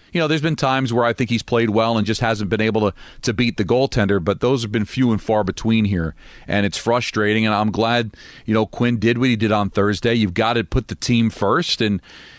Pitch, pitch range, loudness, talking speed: 115 Hz, 105-120 Hz, -19 LUFS, 255 wpm